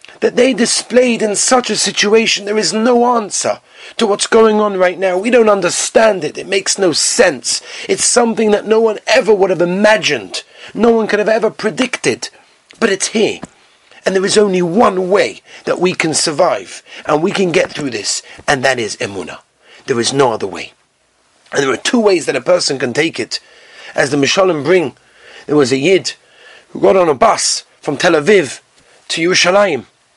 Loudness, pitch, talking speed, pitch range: -13 LUFS, 210 Hz, 195 wpm, 185-235 Hz